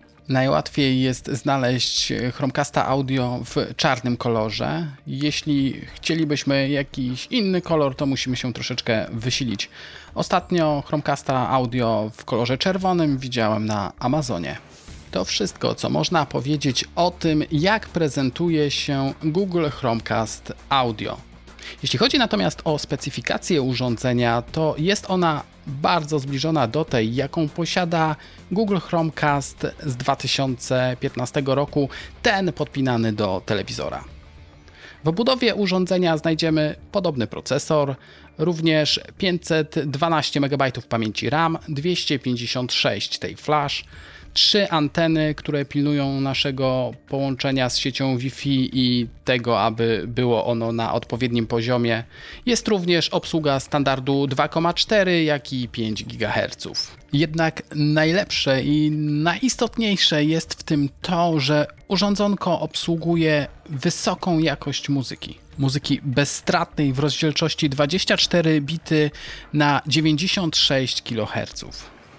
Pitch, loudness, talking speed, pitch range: 145 Hz, -22 LUFS, 105 wpm, 125-160 Hz